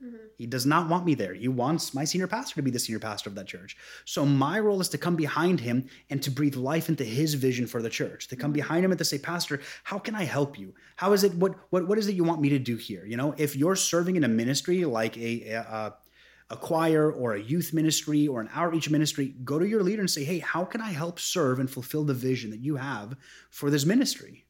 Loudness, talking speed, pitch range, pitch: -27 LUFS, 260 wpm, 130-175 Hz, 150 Hz